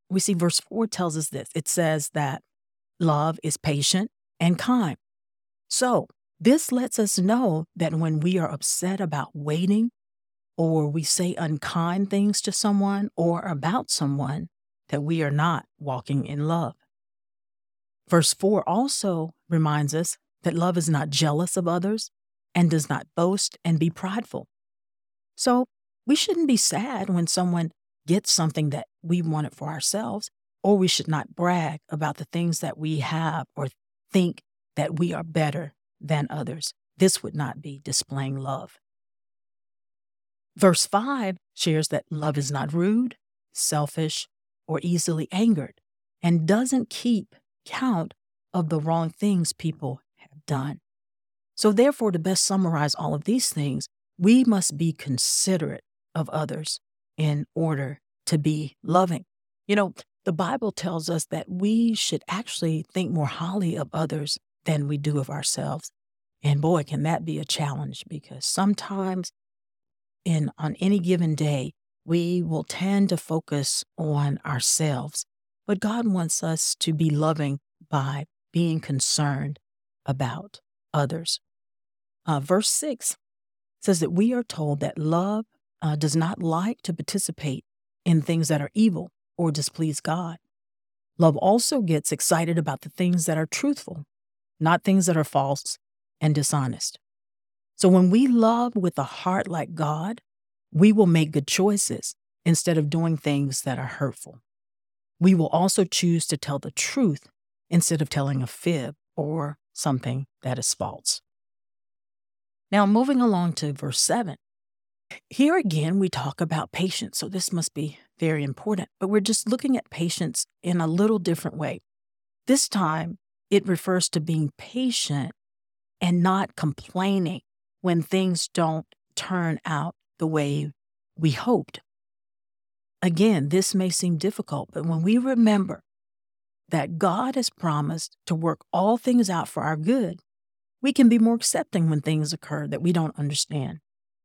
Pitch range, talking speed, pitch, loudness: 145-190 Hz, 150 wpm, 160 Hz, -24 LUFS